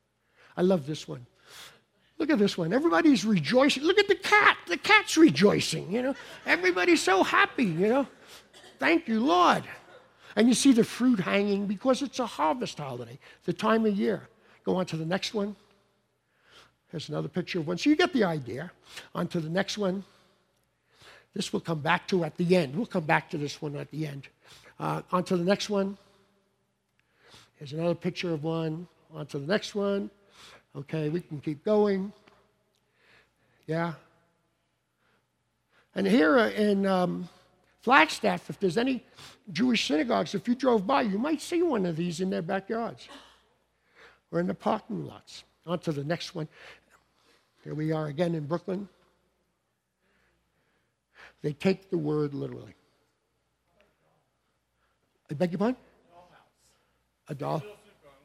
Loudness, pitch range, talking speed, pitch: -27 LUFS, 165-220 Hz, 155 wpm, 185 Hz